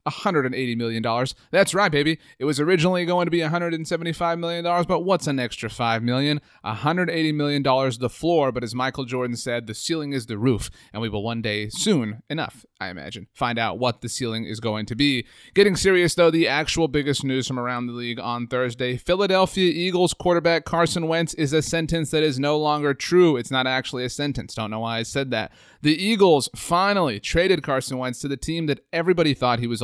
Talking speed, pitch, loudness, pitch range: 205 wpm, 145 Hz, -22 LUFS, 120-170 Hz